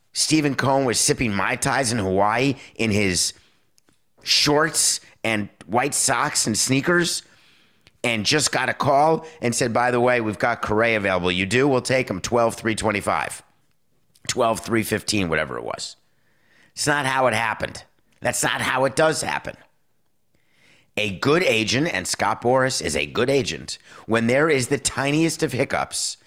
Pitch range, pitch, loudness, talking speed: 110-140 Hz, 125 Hz, -21 LUFS, 155 wpm